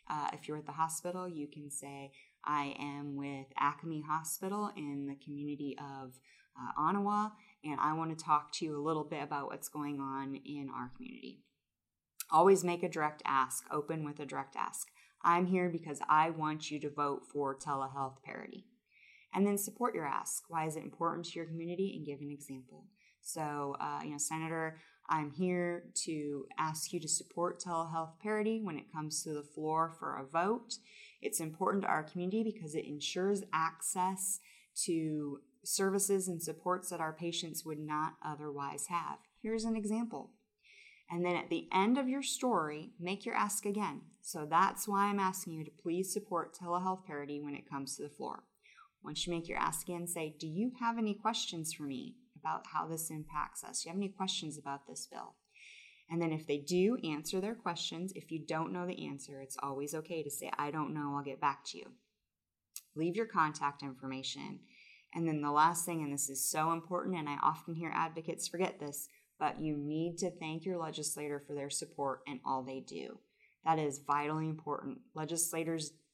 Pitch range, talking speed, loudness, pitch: 145-185 Hz, 190 wpm, -37 LUFS, 160 Hz